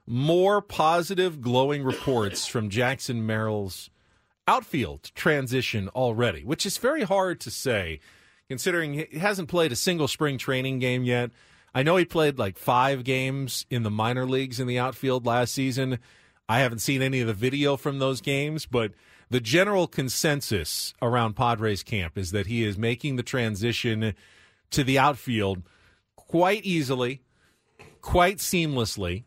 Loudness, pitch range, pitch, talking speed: -25 LUFS, 115-150 Hz, 130 Hz, 150 wpm